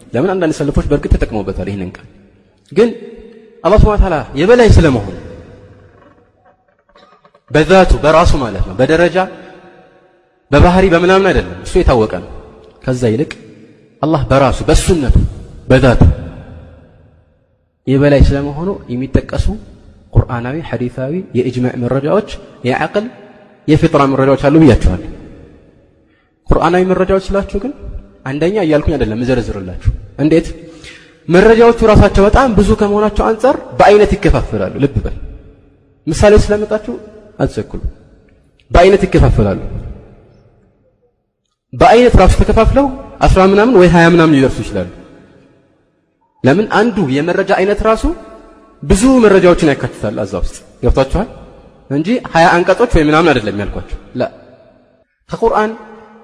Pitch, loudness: 150 Hz, -12 LUFS